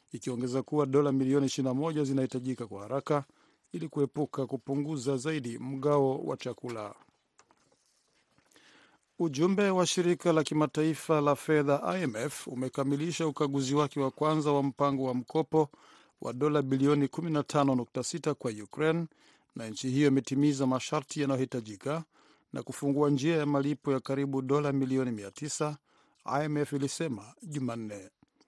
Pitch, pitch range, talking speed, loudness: 140 Hz, 130-150 Hz, 115 wpm, -30 LUFS